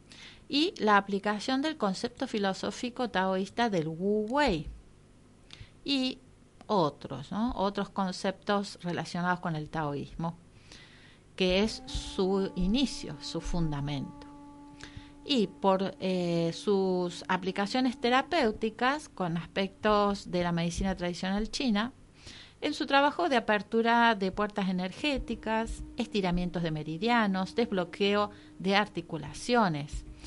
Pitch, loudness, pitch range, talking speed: 195 Hz, -30 LUFS, 175-230 Hz, 105 wpm